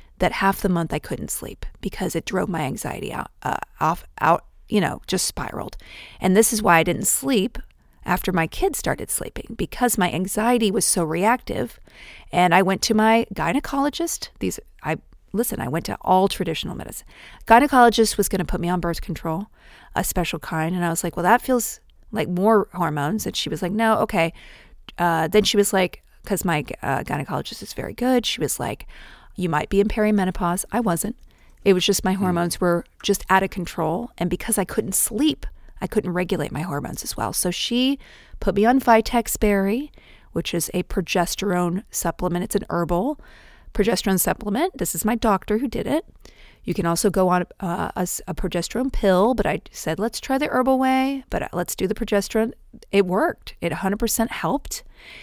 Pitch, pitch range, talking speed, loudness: 195 Hz, 175-225 Hz, 190 wpm, -22 LUFS